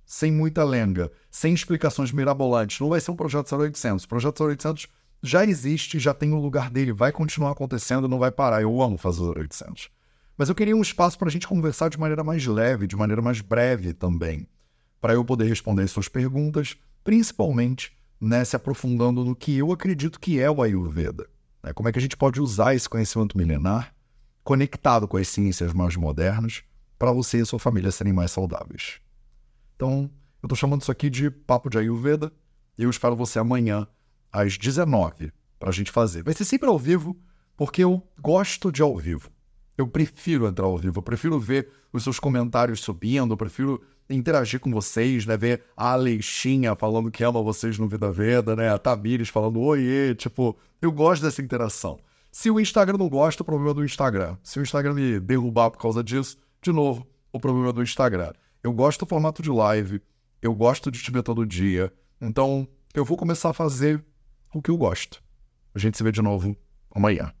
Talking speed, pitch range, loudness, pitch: 195 wpm, 110-145 Hz, -24 LUFS, 125 Hz